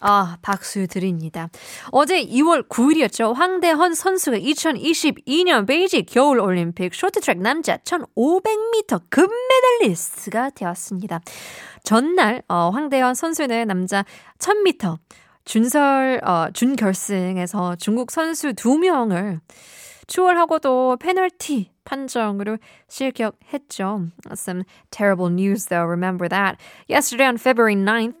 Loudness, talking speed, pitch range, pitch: -19 LUFS, 310 characters per minute, 195-320 Hz, 240 Hz